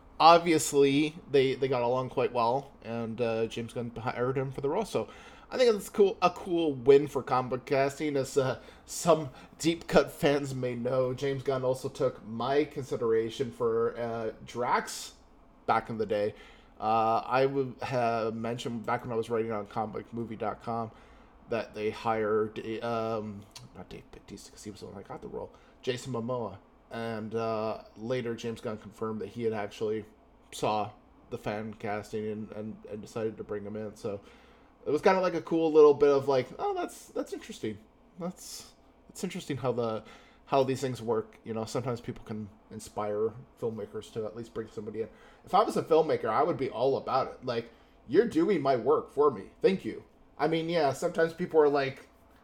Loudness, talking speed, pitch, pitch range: -30 LUFS, 190 wpm, 125 Hz, 110-150 Hz